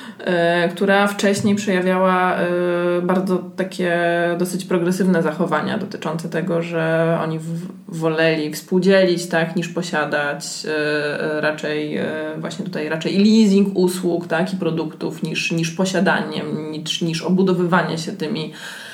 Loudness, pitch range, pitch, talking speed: -19 LUFS, 160-185 Hz, 175 Hz, 110 wpm